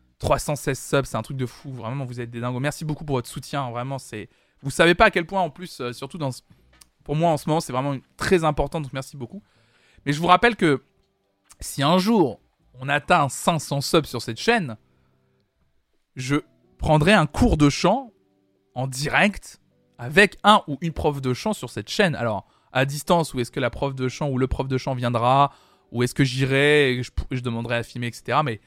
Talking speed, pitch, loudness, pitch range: 220 wpm, 140 Hz, -22 LUFS, 120-155 Hz